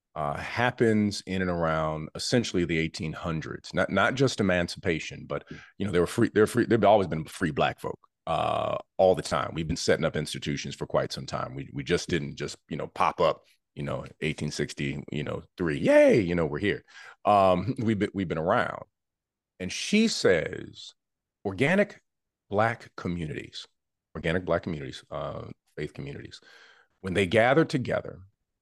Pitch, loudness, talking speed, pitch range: 95 Hz, -27 LUFS, 170 wpm, 80-115 Hz